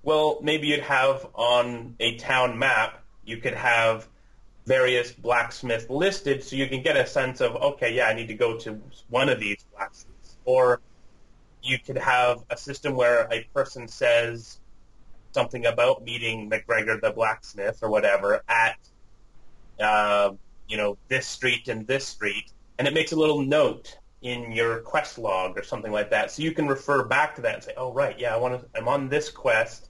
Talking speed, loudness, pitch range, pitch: 185 wpm, -24 LUFS, 110-135 Hz, 125 Hz